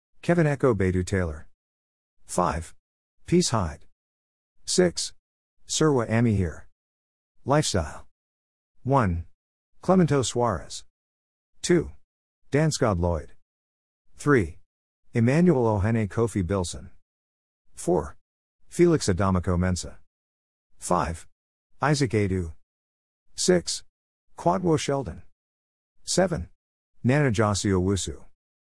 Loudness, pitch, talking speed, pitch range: -25 LUFS, 90 Hz, 75 wpm, 70-115 Hz